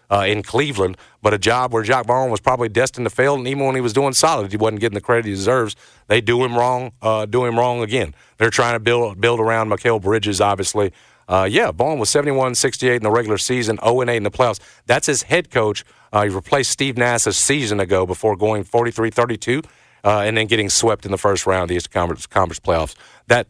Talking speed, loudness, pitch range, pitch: 230 wpm, -18 LUFS, 105-125 Hz, 115 Hz